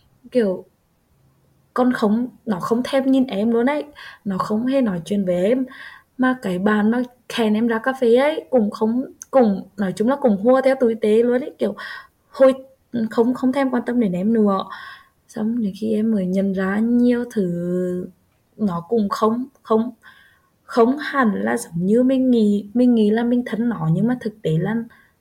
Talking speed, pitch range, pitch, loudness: 195 wpm, 210-255 Hz, 230 Hz, -20 LUFS